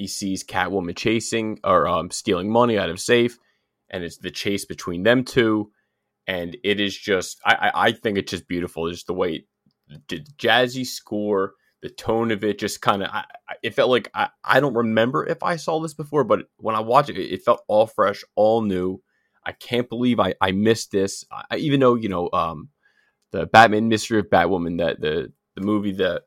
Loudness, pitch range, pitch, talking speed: -21 LUFS, 95-120 Hz, 105 Hz, 210 wpm